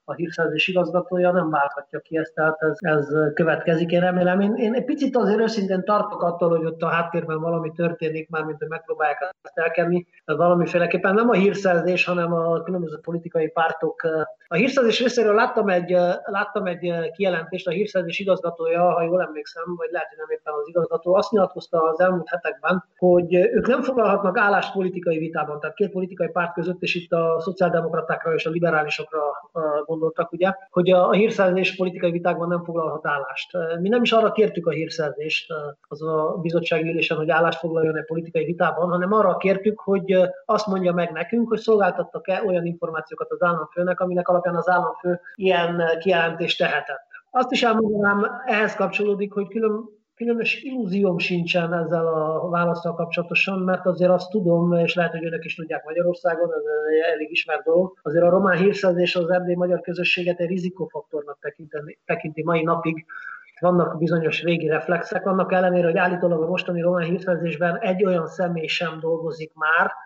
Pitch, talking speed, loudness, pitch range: 175 Hz, 170 wpm, -22 LUFS, 165-185 Hz